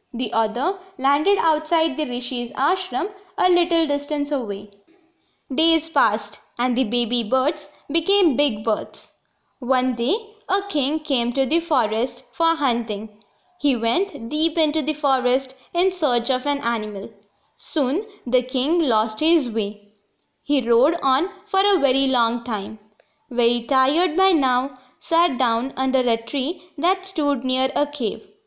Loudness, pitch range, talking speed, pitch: -21 LUFS, 245-330 Hz, 145 wpm, 275 Hz